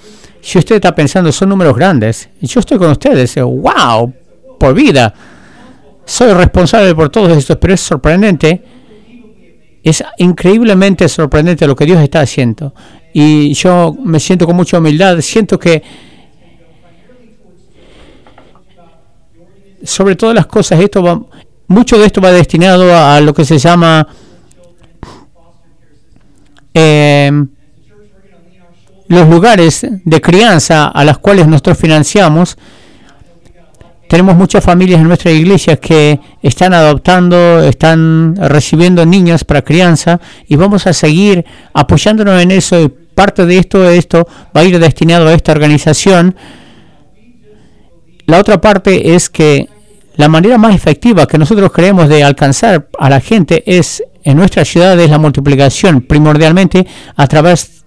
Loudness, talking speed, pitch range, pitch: -7 LUFS, 130 wpm, 150-185 Hz, 170 Hz